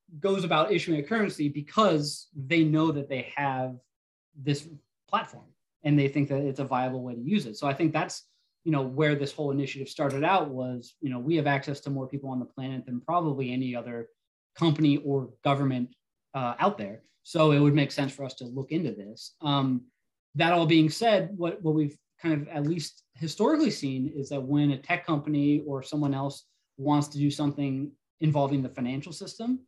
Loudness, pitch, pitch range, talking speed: -28 LUFS, 145 Hz, 135-155 Hz, 200 wpm